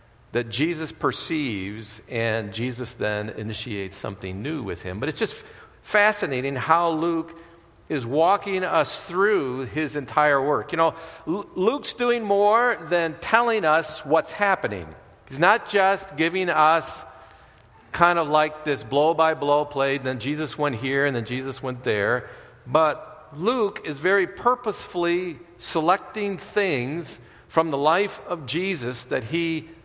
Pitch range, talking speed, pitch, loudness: 130-180 Hz, 145 wpm, 155 Hz, -23 LUFS